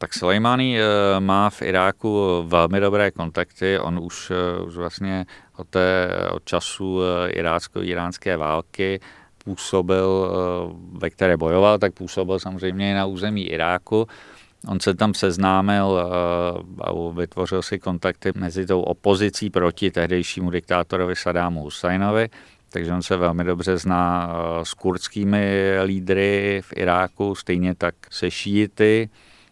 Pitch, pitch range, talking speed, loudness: 95 Hz, 90-100 Hz, 120 wpm, -22 LUFS